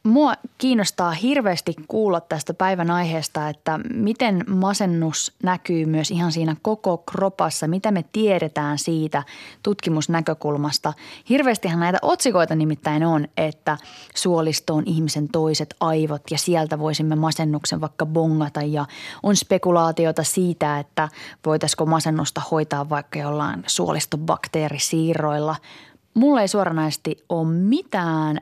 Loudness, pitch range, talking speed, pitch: -22 LUFS, 155-190 Hz, 115 wpm, 160 Hz